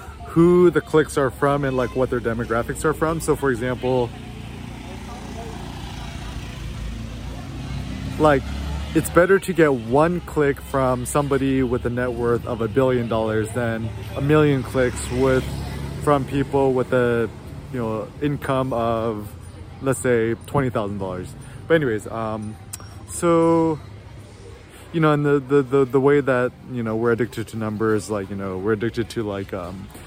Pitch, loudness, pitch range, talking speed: 125 Hz, -21 LUFS, 110-140 Hz, 155 wpm